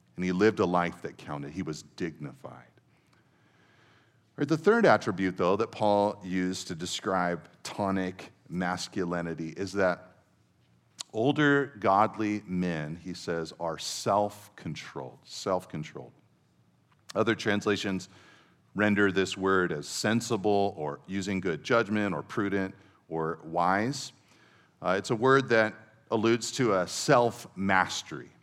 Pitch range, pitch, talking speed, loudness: 90-110 Hz, 100 Hz, 120 wpm, -29 LUFS